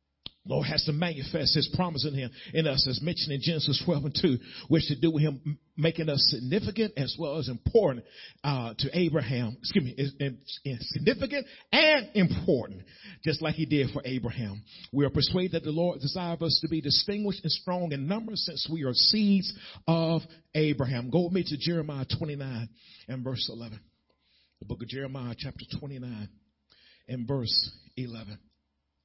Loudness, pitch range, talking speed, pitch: -28 LUFS, 125-165 Hz, 175 wpm, 145 Hz